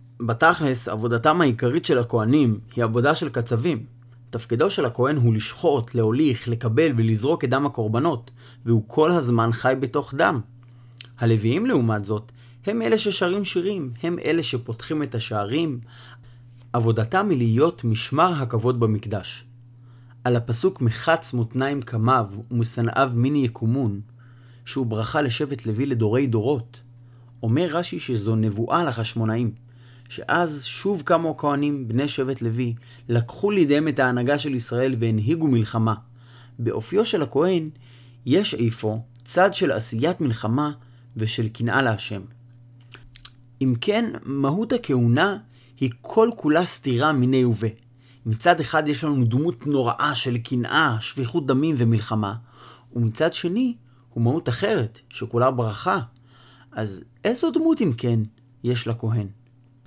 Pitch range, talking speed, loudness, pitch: 115-145 Hz, 125 wpm, -23 LUFS, 120 Hz